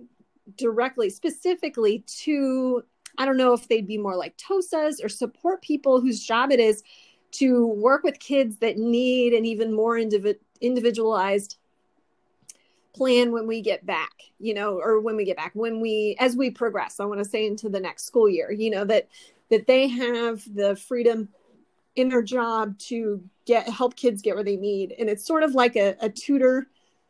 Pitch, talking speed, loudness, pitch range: 230 Hz, 185 wpm, -24 LUFS, 215-255 Hz